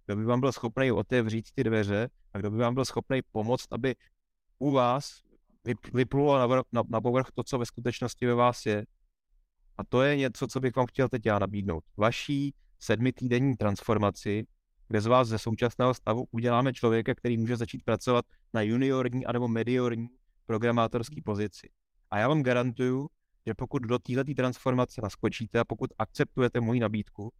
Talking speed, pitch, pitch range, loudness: 165 wpm, 120 Hz, 110-130 Hz, -29 LUFS